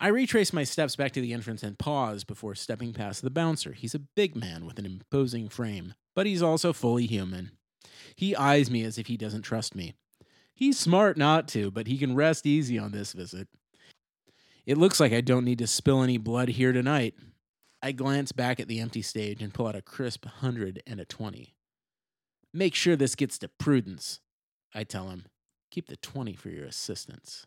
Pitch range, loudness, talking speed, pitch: 110-145 Hz, -28 LUFS, 200 wpm, 125 Hz